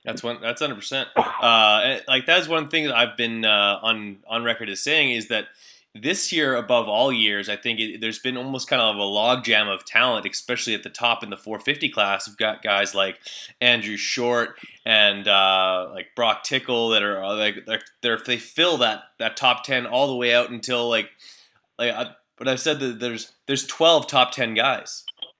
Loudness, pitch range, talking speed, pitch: -21 LUFS, 105-130 Hz, 205 wpm, 120 Hz